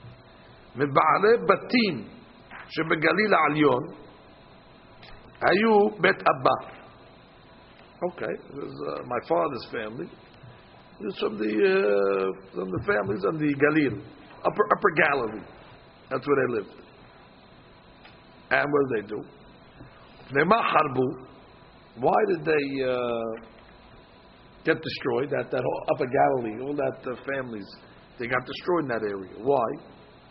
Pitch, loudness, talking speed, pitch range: 130 Hz, -25 LUFS, 100 wpm, 110-155 Hz